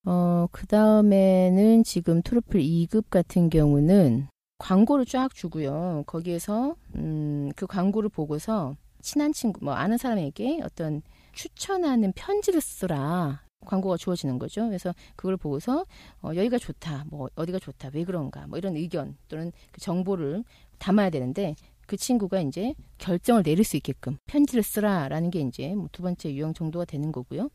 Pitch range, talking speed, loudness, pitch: 155-215 Hz, 320 characters per minute, -26 LUFS, 180 Hz